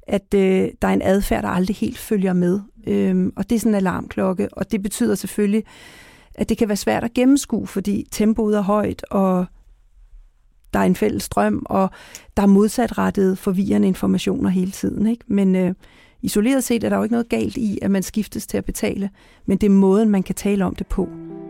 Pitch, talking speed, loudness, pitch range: 200 Hz, 210 wpm, -20 LUFS, 190-220 Hz